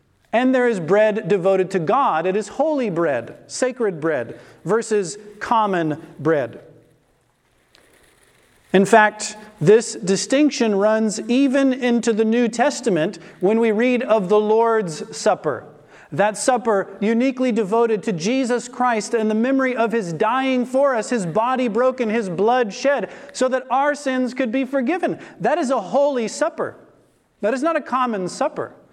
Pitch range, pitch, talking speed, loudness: 210-255 Hz, 230 Hz, 150 wpm, -19 LUFS